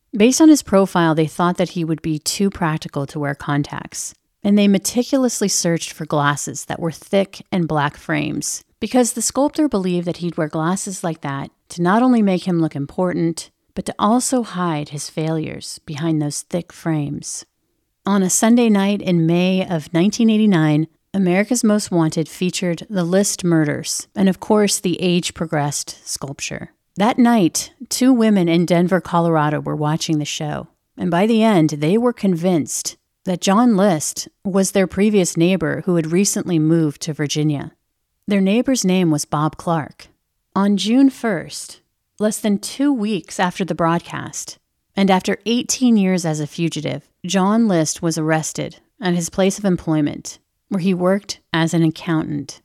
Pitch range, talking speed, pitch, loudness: 160-200 Hz, 165 wpm, 180 Hz, -18 LUFS